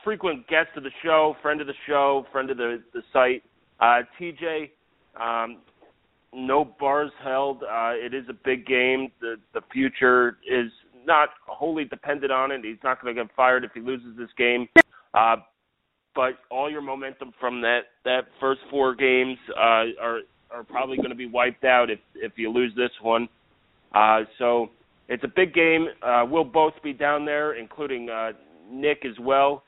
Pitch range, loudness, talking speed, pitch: 120-145 Hz, -23 LUFS, 180 wpm, 130 Hz